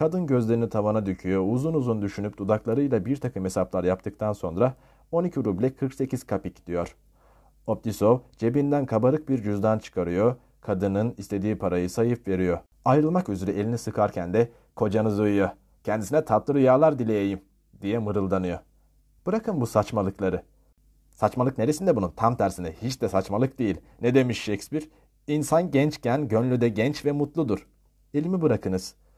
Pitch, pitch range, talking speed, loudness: 110 Hz, 100-135 Hz, 135 wpm, -25 LUFS